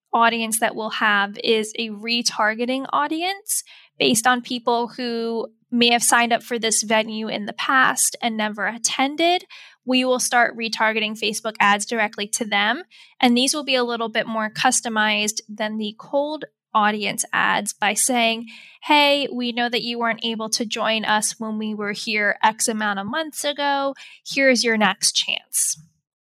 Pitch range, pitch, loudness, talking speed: 215-250 Hz, 230 Hz, -20 LUFS, 165 wpm